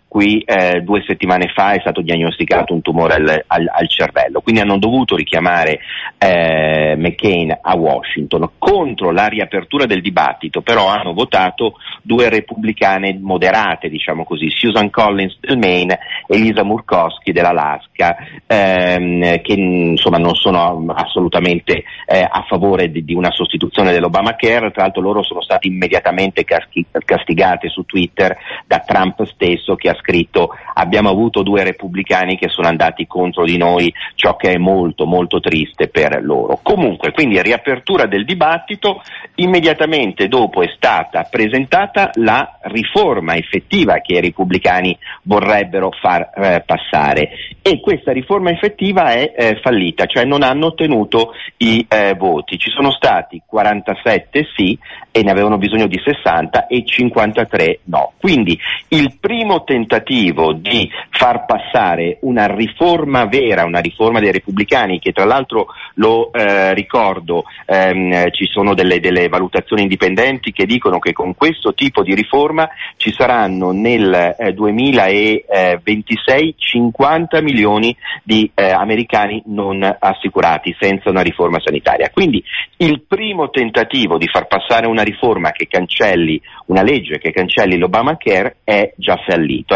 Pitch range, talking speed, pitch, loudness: 90-120 Hz, 140 wpm, 105 Hz, -14 LUFS